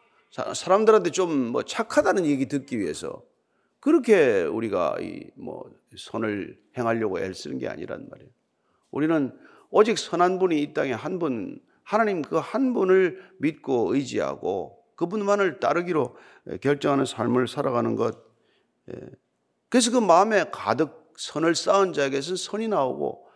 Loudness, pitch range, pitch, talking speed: -24 LUFS, 150-220 Hz, 185 Hz, 290 characters per minute